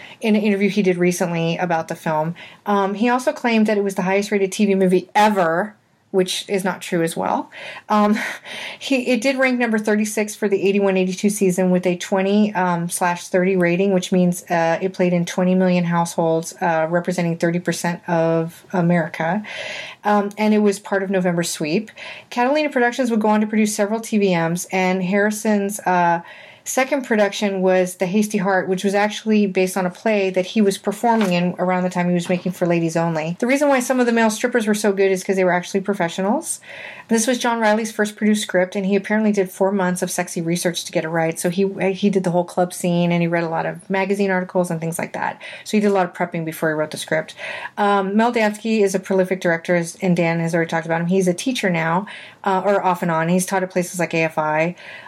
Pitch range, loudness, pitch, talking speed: 175-210 Hz, -19 LUFS, 190 Hz, 225 wpm